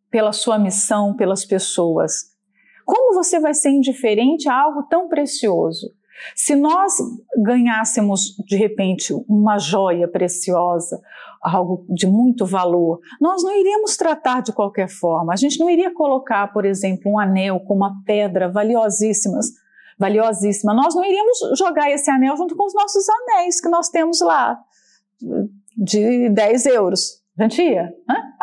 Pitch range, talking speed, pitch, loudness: 195-300 Hz, 140 wpm, 220 Hz, -17 LUFS